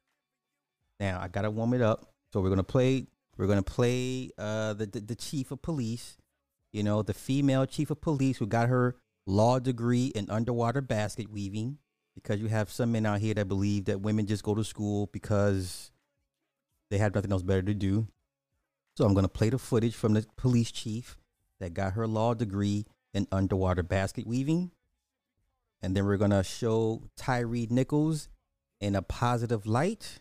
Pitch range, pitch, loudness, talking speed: 100-120 Hz, 110 Hz, -30 LUFS, 175 wpm